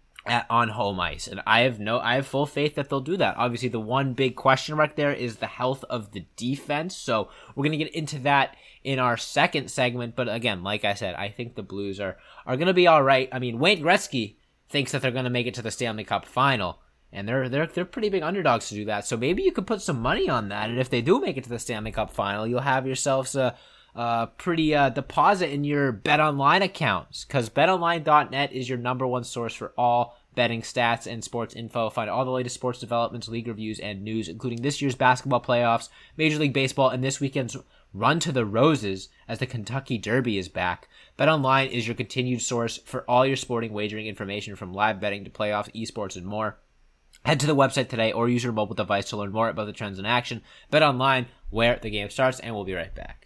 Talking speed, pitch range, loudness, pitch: 230 wpm, 110-135 Hz, -25 LUFS, 125 Hz